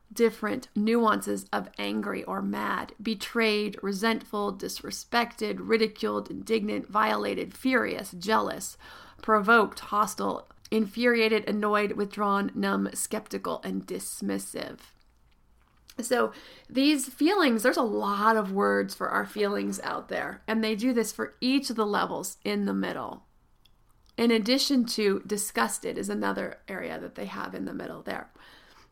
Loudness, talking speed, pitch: -28 LUFS, 130 wpm, 215 Hz